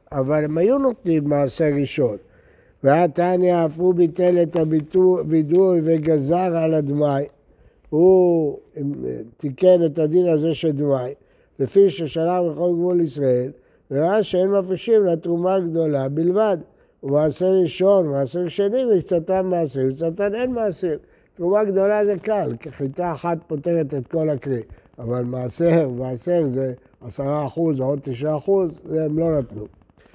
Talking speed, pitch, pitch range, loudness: 130 wpm, 165 Hz, 140-180 Hz, -20 LUFS